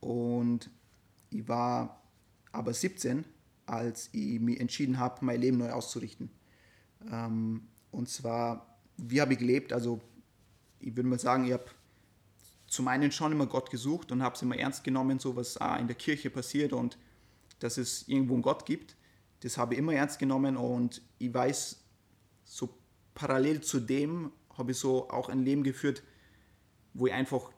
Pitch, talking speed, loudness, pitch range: 125 Hz, 165 wpm, -33 LUFS, 115-135 Hz